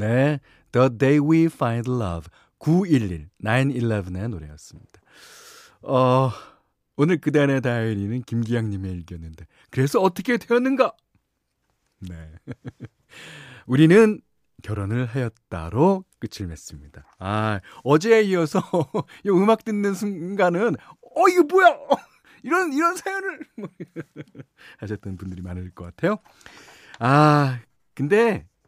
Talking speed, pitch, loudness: 235 characters per minute, 130 Hz, -21 LUFS